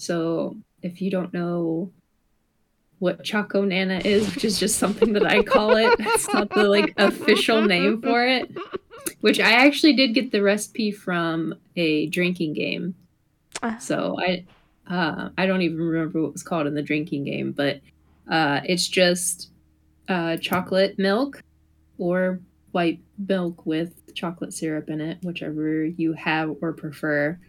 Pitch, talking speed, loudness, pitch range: 180 Hz, 155 wpm, -22 LUFS, 160-205 Hz